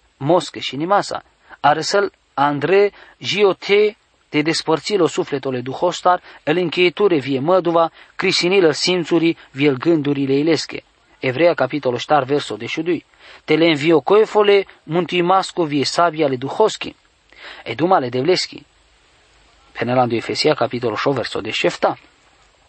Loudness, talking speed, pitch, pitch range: -18 LUFS, 120 wpm, 165 Hz, 140-180 Hz